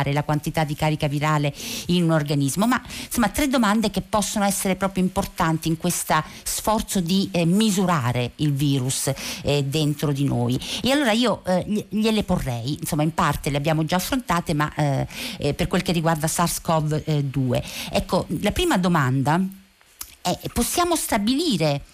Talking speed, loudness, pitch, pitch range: 155 wpm, -22 LUFS, 170 Hz, 150-200 Hz